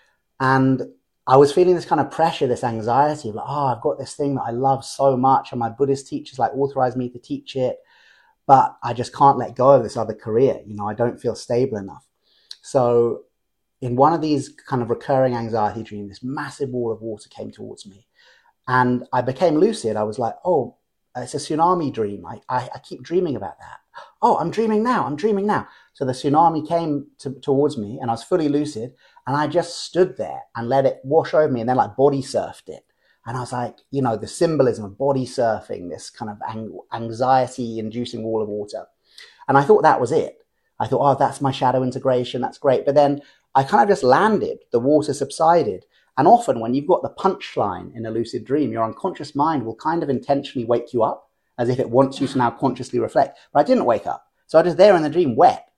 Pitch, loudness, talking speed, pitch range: 130 Hz, -20 LUFS, 225 wpm, 120-145 Hz